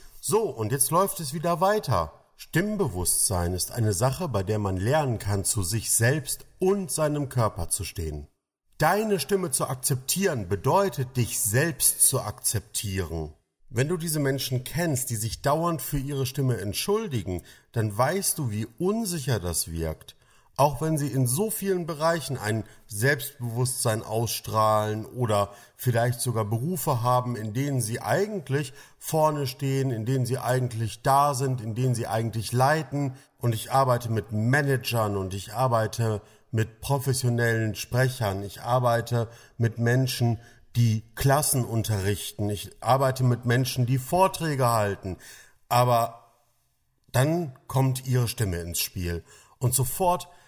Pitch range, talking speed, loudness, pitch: 110-140 Hz, 140 wpm, -26 LUFS, 125 Hz